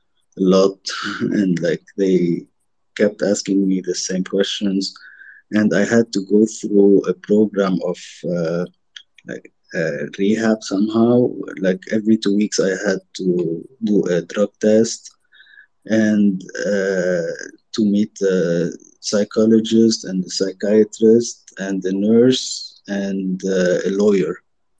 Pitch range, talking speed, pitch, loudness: 95-110 Hz, 125 wpm, 100 Hz, -18 LUFS